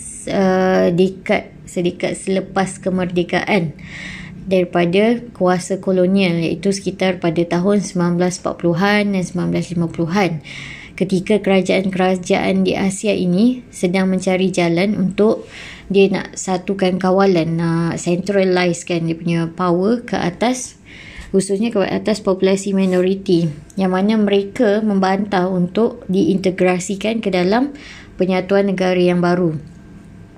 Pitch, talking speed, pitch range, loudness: 185 Hz, 105 wpm, 175-195 Hz, -17 LUFS